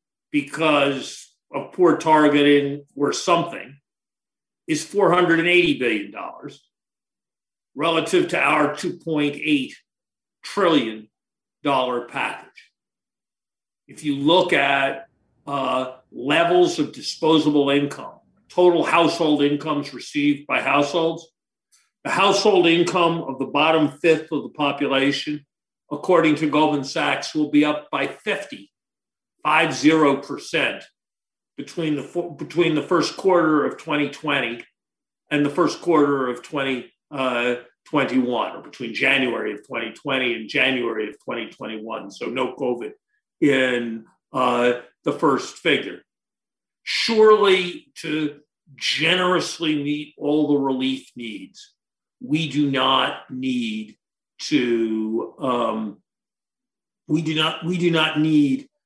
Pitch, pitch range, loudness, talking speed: 150 Hz, 140-175 Hz, -21 LUFS, 105 wpm